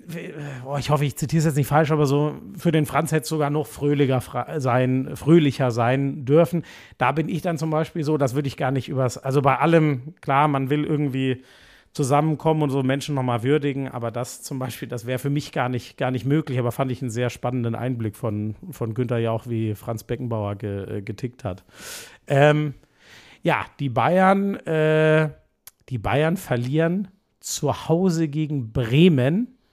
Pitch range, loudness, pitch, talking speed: 125-155 Hz, -22 LUFS, 140 Hz, 185 wpm